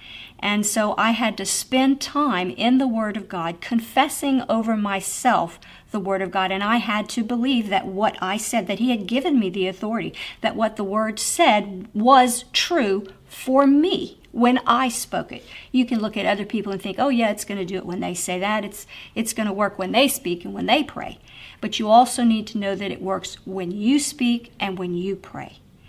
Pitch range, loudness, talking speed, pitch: 195-245 Hz, -21 LUFS, 220 wpm, 215 Hz